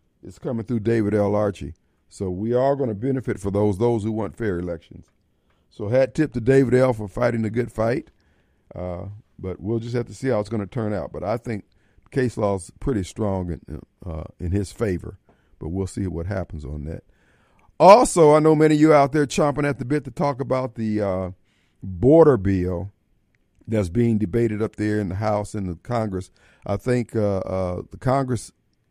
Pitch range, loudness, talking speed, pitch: 95-125 Hz, -22 LUFS, 205 wpm, 105 Hz